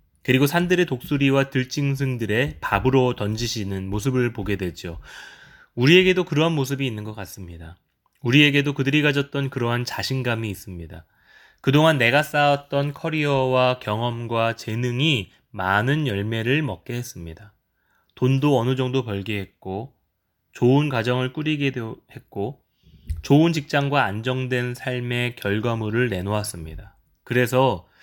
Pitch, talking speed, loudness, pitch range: 125 Hz, 305 characters per minute, -22 LUFS, 105-140 Hz